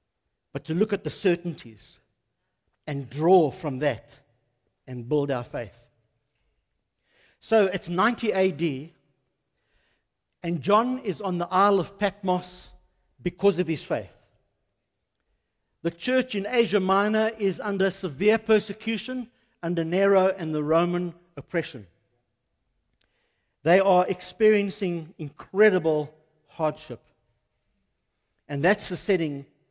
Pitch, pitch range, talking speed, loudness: 170 Hz, 130-195 Hz, 110 wpm, -25 LUFS